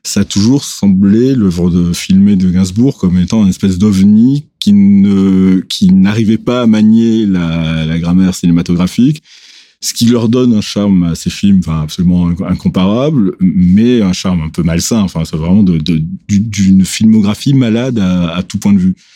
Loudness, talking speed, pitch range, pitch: -10 LUFS, 175 wpm, 90-120 Hz, 100 Hz